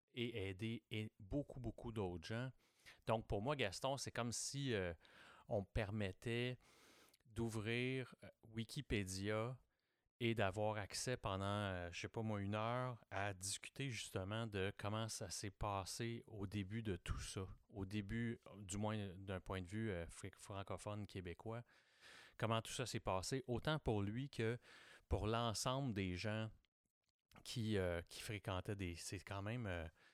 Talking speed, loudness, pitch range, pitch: 155 wpm, -46 LUFS, 95-115 Hz, 110 Hz